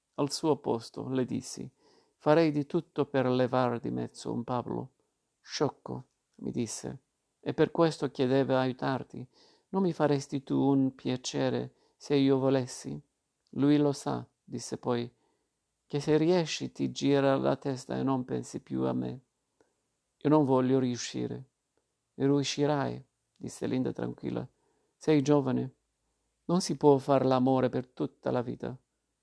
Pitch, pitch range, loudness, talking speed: 135 Hz, 120-145 Hz, -30 LUFS, 140 wpm